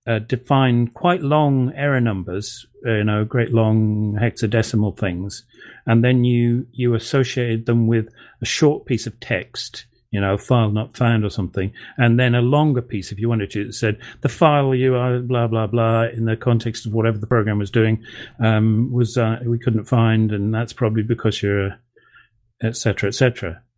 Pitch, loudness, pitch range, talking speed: 115 Hz, -19 LUFS, 110-120 Hz, 190 wpm